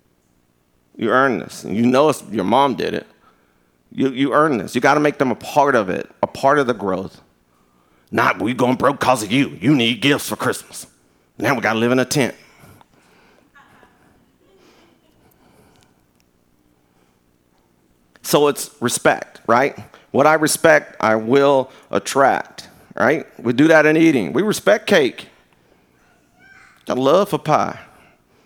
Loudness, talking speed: -17 LUFS, 150 wpm